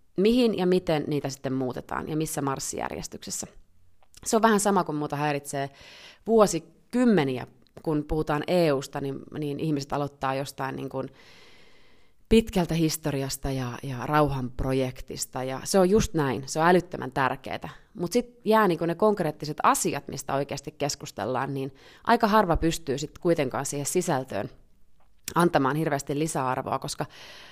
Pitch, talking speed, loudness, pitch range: 150 Hz, 135 wpm, -26 LUFS, 135-170 Hz